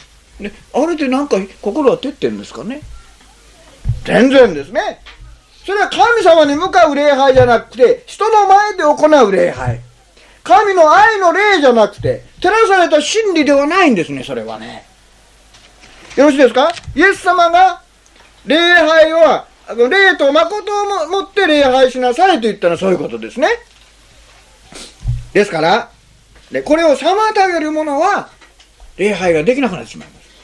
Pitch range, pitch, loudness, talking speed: 250-380 Hz, 310 Hz, -12 LUFS, 280 characters per minute